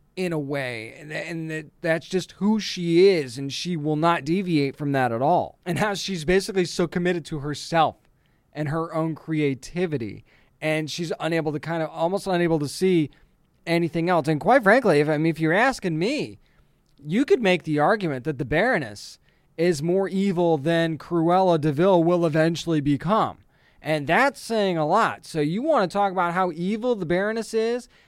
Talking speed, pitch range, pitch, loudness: 185 wpm, 155-185 Hz, 170 Hz, -23 LUFS